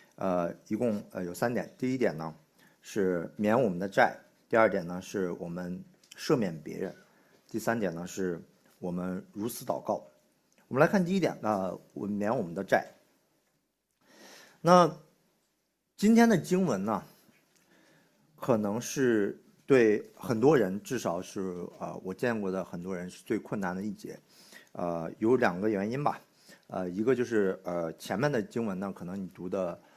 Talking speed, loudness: 220 characters per minute, -30 LUFS